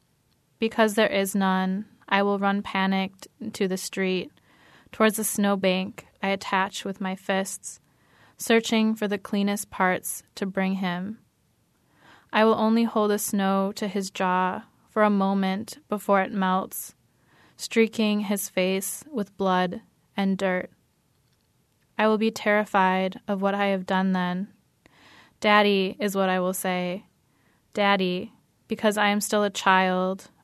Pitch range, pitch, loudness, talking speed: 185-210 Hz, 195 Hz, -25 LUFS, 145 wpm